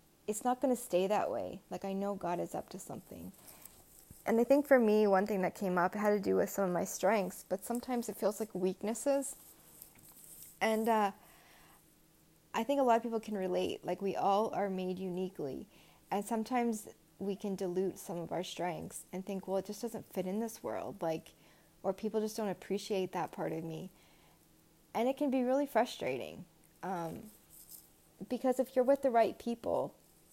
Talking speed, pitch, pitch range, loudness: 195 wpm, 205 Hz, 185-230 Hz, -35 LUFS